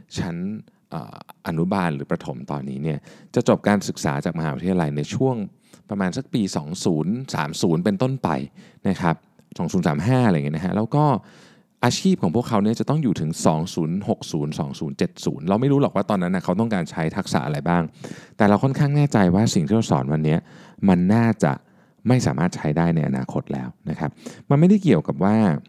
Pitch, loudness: 115 Hz, -22 LUFS